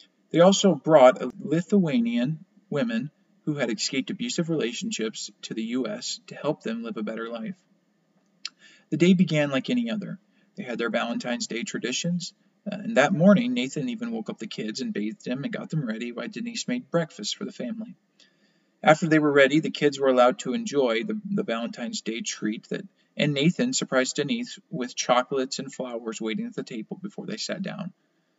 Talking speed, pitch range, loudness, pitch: 185 wpm, 140-215 Hz, -25 LUFS, 195 Hz